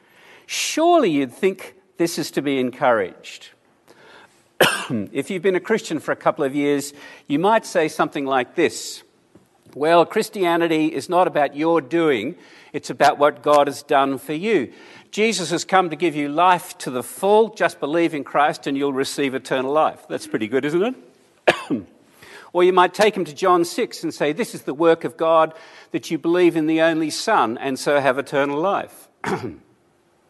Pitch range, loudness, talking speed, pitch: 145-180 Hz, -20 LUFS, 180 wpm, 160 Hz